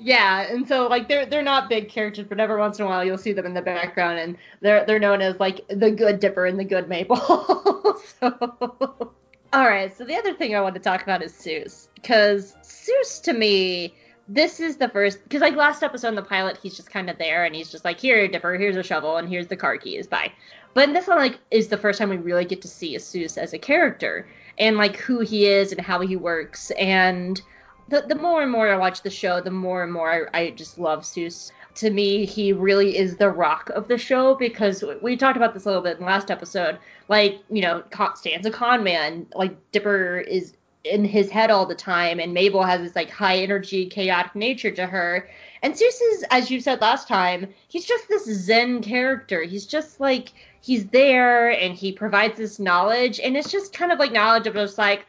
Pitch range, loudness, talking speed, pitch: 185-245 Hz, -21 LUFS, 230 wpm, 205 Hz